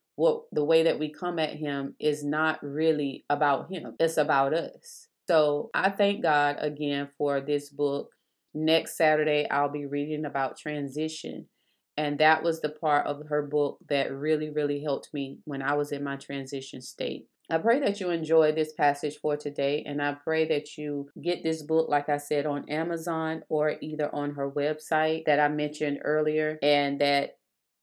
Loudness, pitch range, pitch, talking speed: -28 LUFS, 145-155 Hz, 150 Hz, 180 wpm